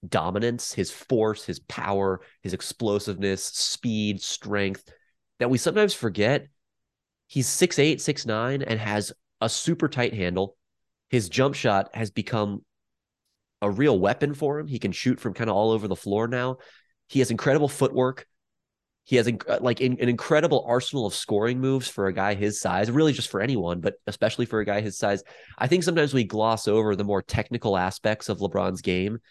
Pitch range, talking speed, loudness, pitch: 100-130 Hz, 180 wpm, -25 LUFS, 115 Hz